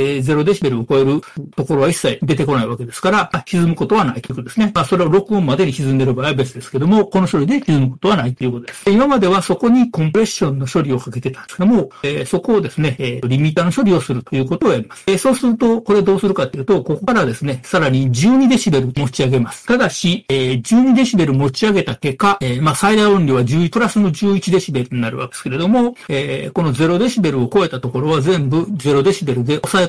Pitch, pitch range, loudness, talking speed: 165 Hz, 135-200 Hz, -16 LUFS, 480 characters per minute